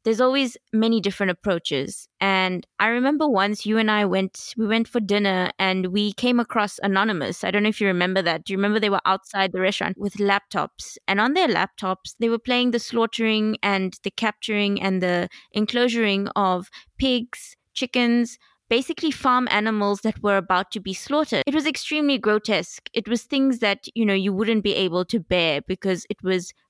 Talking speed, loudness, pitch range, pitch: 190 wpm, -22 LUFS, 195-235 Hz, 210 Hz